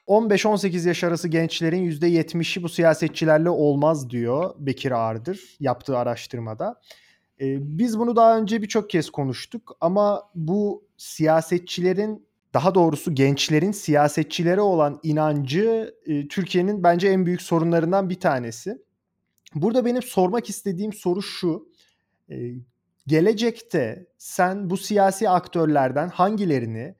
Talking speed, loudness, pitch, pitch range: 115 wpm, -22 LUFS, 175 Hz, 155-195 Hz